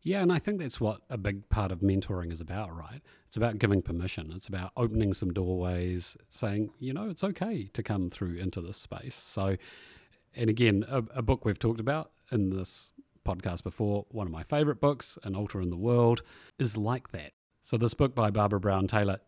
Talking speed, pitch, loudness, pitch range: 210 wpm, 105 Hz, -31 LUFS, 95-125 Hz